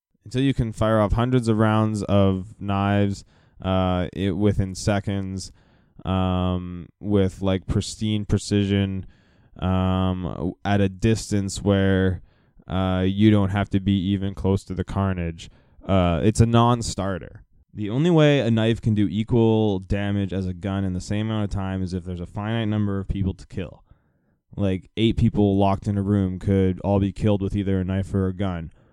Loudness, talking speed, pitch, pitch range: -23 LUFS, 175 wpm, 100 Hz, 95-105 Hz